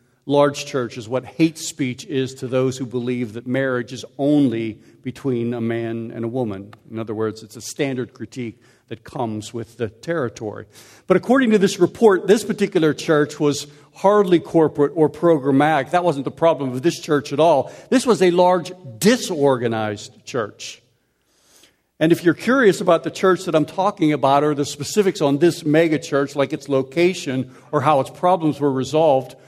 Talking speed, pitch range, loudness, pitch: 180 wpm, 125-165 Hz, -19 LUFS, 145 Hz